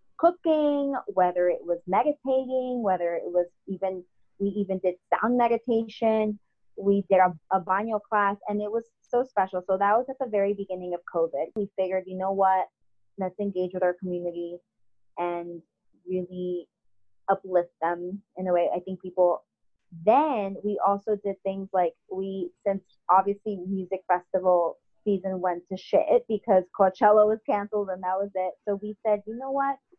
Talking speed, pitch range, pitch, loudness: 165 wpm, 180-210 Hz, 190 Hz, -27 LUFS